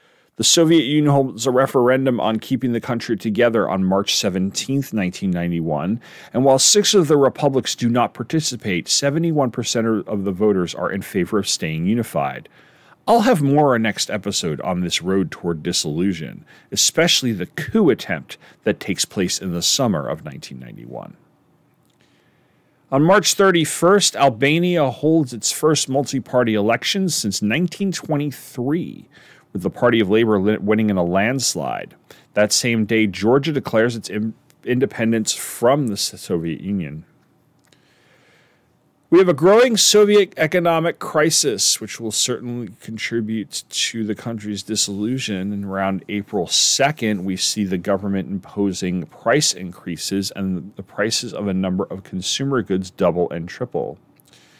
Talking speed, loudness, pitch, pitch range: 140 wpm, -19 LUFS, 115 Hz, 100-145 Hz